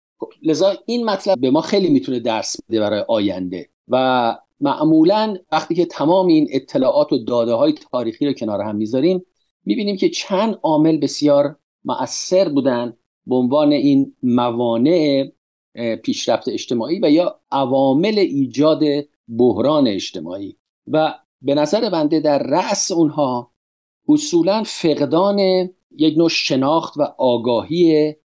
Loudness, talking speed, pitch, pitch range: -17 LUFS, 125 wpm, 155 Hz, 135-220 Hz